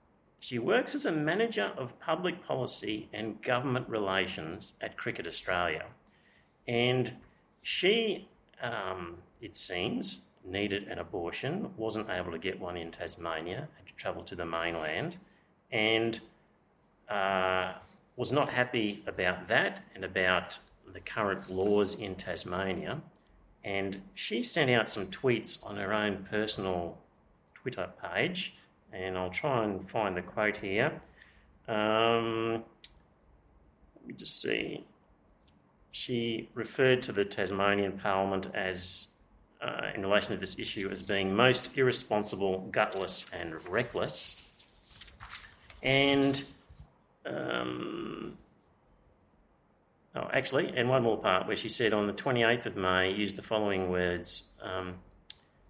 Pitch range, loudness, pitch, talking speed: 95-115 Hz, -32 LUFS, 100 Hz, 125 wpm